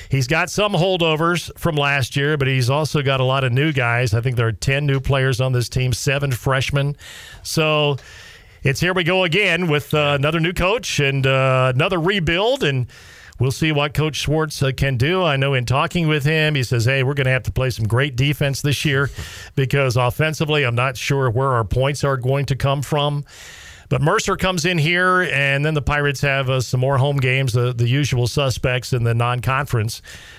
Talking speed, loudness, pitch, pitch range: 215 wpm, -18 LUFS, 140 Hz, 130-150 Hz